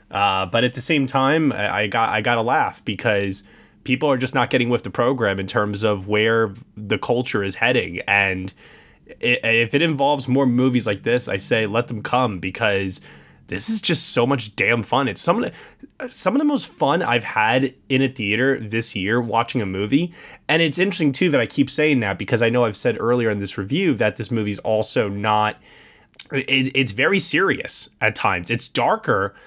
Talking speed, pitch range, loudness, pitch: 205 wpm, 105-135 Hz, -19 LUFS, 120 Hz